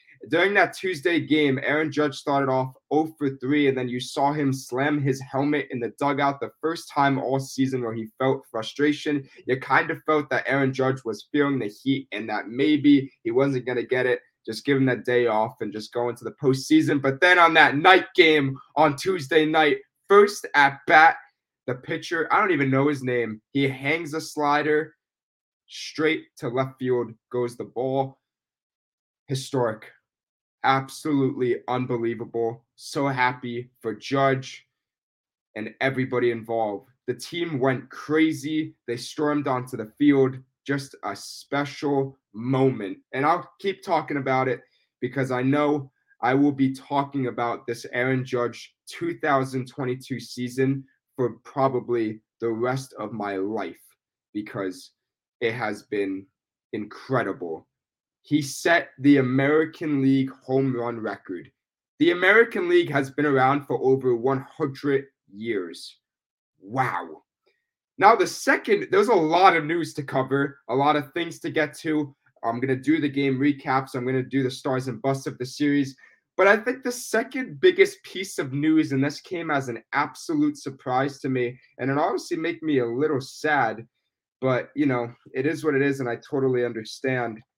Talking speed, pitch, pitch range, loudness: 165 wpm, 135 Hz, 125-150 Hz, -24 LUFS